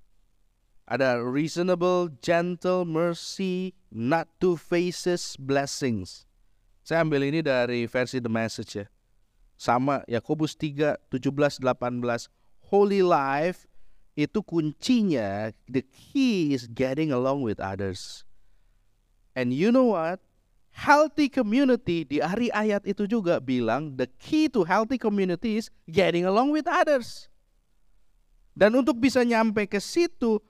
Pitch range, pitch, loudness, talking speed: 120-200 Hz, 155 Hz, -25 LUFS, 120 wpm